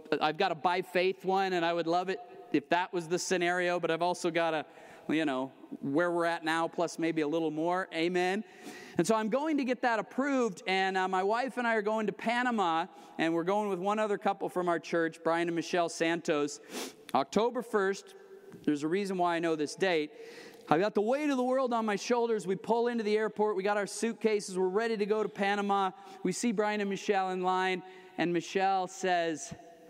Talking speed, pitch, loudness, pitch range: 220 wpm, 190 Hz, -31 LUFS, 170-215 Hz